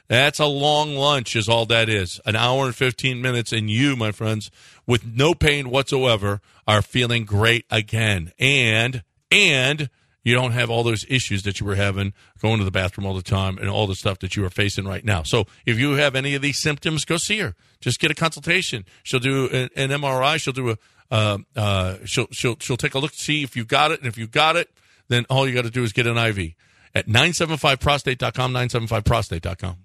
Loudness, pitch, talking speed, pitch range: -20 LUFS, 120 Hz, 220 wpm, 105-135 Hz